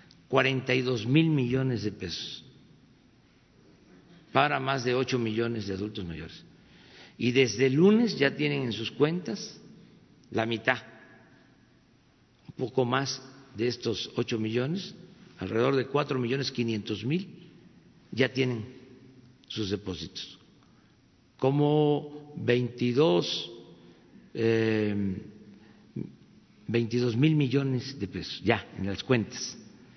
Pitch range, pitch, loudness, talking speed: 110-135 Hz, 125 Hz, -28 LUFS, 110 wpm